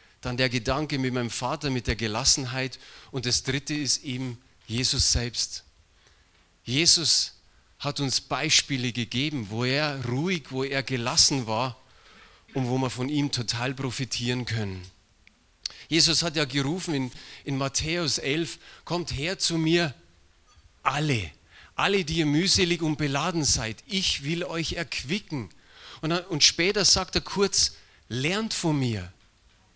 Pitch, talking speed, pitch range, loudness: 135 Hz, 140 wpm, 120-160 Hz, -25 LUFS